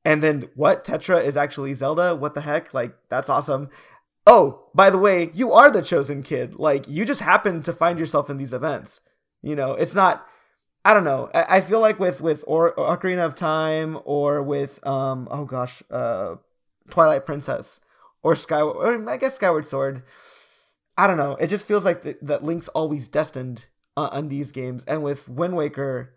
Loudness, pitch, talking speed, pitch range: -21 LUFS, 155 Hz, 185 wpm, 140-170 Hz